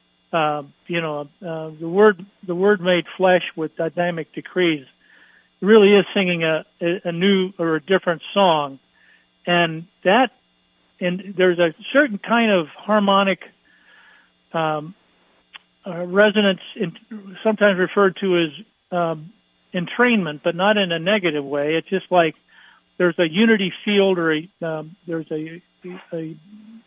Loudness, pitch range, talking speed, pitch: -20 LUFS, 165-200 Hz, 140 wpm, 180 Hz